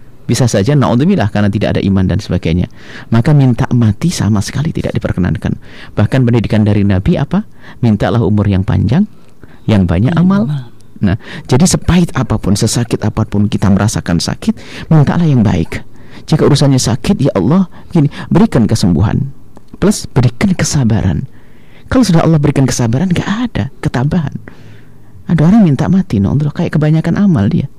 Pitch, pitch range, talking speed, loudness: 125 Hz, 105-160 Hz, 150 wpm, -12 LUFS